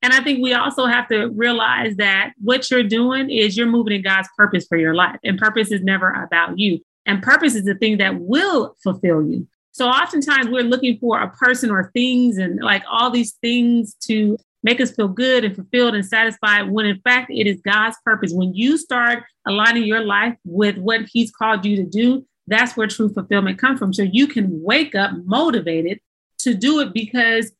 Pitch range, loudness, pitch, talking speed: 200-245 Hz, -17 LUFS, 225 Hz, 205 wpm